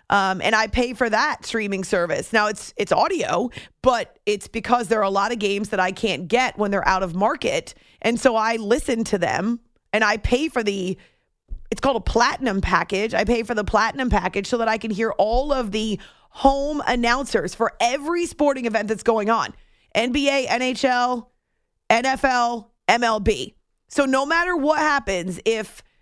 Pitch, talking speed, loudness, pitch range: 230 Hz, 180 wpm, -21 LUFS, 210-255 Hz